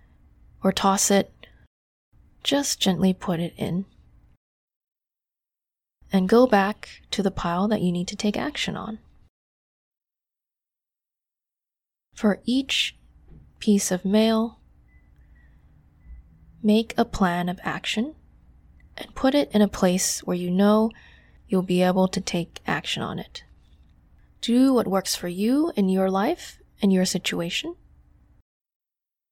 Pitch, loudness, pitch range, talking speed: 190 Hz, -23 LUFS, 175-215 Hz, 120 wpm